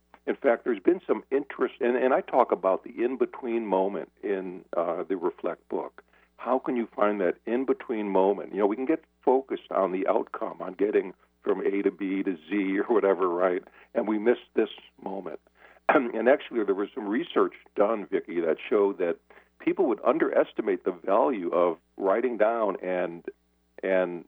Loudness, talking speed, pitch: -27 LUFS, 185 wpm, 160 Hz